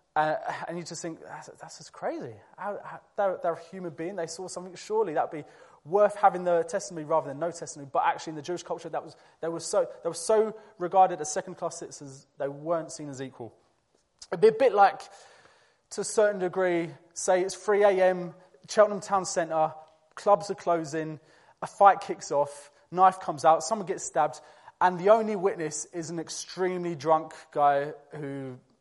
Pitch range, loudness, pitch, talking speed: 155-190 Hz, -27 LUFS, 170 Hz, 190 wpm